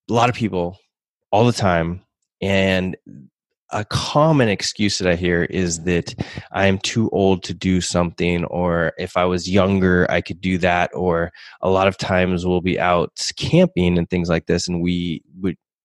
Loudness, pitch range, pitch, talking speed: -19 LUFS, 85-95 Hz, 90 Hz, 180 wpm